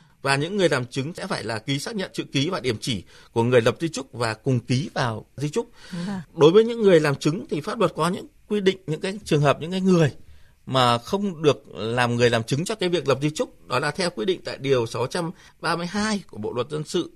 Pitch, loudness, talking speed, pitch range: 155 Hz, -23 LUFS, 255 wpm, 135-190 Hz